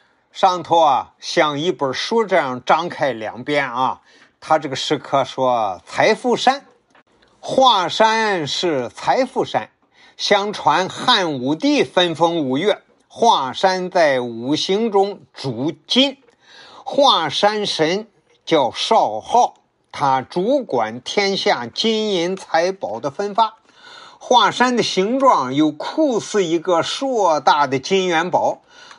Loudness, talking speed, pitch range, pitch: -18 LUFS, 165 characters per minute, 155-230 Hz, 190 Hz